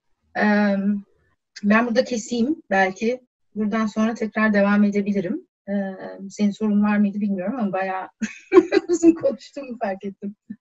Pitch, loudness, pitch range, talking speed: 215 Hz, -21 LUFS, 200-240 Hz, 115 wpm